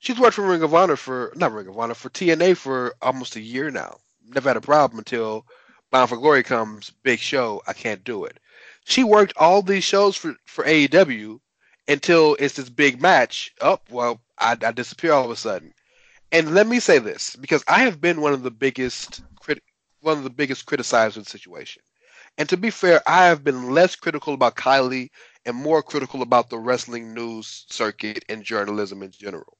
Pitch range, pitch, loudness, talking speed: 120-170 Hz, 140 Hz, -20 LUFS, 205 wpm